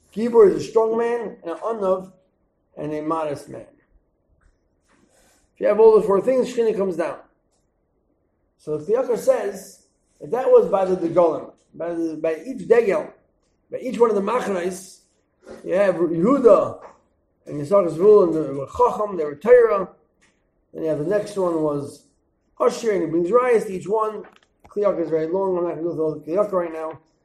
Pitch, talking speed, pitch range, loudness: 185 Hz, 180 wpm, 160-225 Hz, -20 LUFS